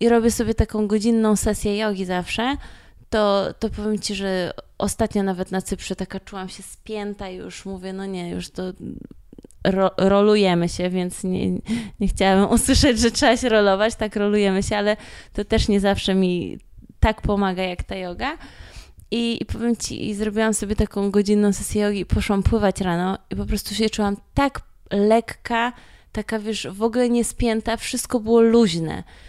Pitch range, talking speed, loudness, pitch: 190-225 Hz, 175 wpm, -21 LUFS, 205 Hz